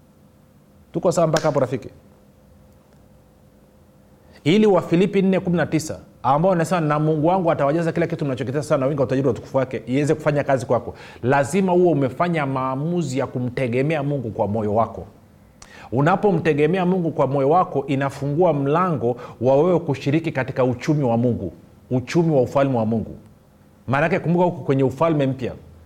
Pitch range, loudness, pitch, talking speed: 125-165 Hz, -20 LUFS, 140 Hz, 130 wpm